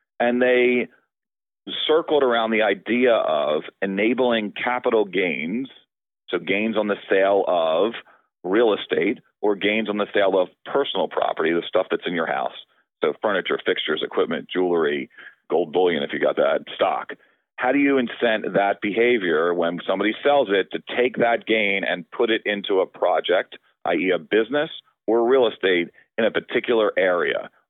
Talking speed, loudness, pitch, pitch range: 160 wpm, -21 LUFS, 110 Hz, 100-125 Hz